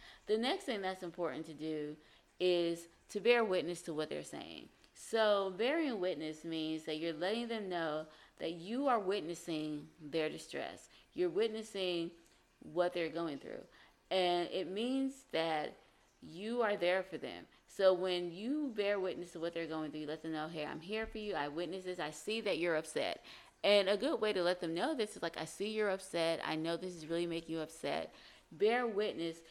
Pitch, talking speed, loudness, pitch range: 175 Hz, 195 wpm, -37 LUFS, 160-205 Hz